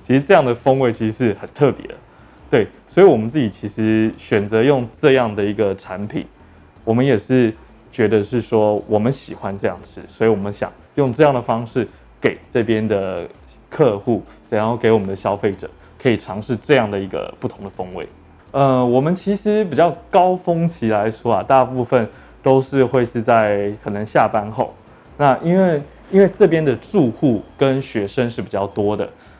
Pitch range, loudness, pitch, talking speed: 105-135 Hz, -18 LUFS, 120 Hz, 270 characters per minute